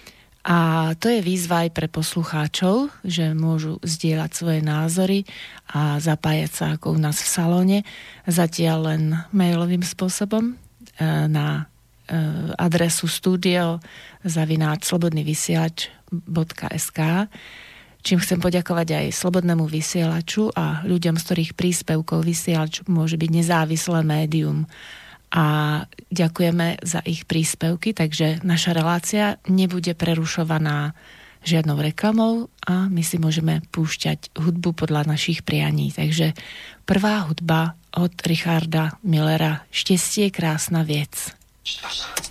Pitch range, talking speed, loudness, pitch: 160-180 Hz, 105 wpm, -22 LUFS, 165 Hz